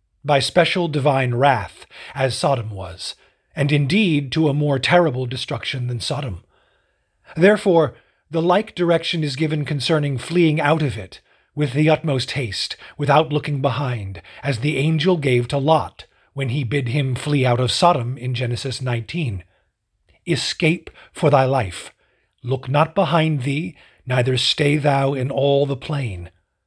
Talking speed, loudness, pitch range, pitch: 150 wpm, -19 LUFS, 125-155 Hz, 140 Hz